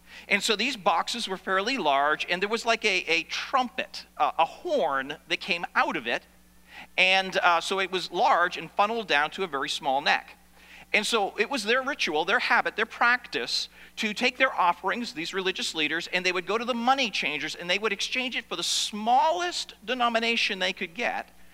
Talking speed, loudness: 205 wpm, -26 LUFS